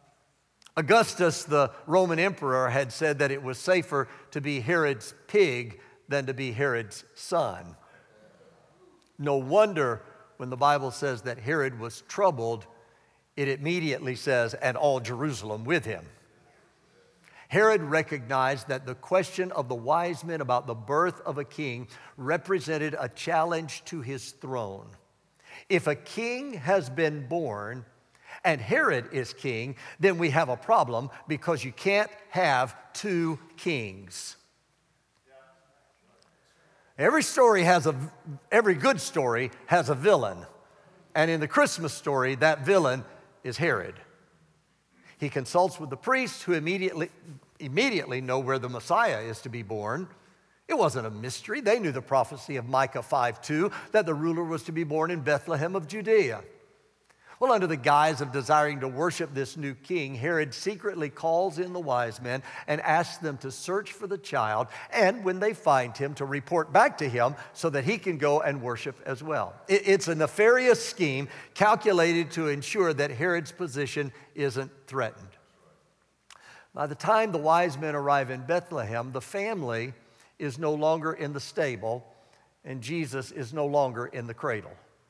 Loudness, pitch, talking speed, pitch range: -27 LUFS, 150 Hz, 155 wpm, 130-175 Hz